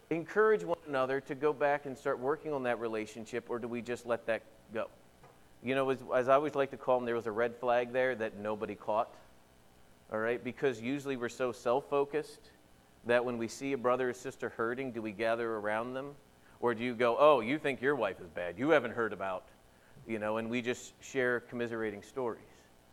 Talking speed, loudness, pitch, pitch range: 215 wpm, -34 LUFS, 120 Hz, 110-135 Hz